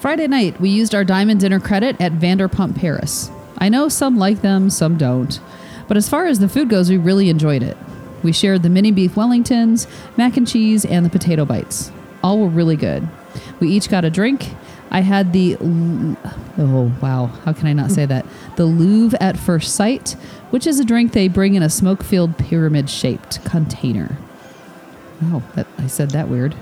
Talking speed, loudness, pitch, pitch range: 195 wpm, -16 LUFS, 185 Hz, 160-210 Hz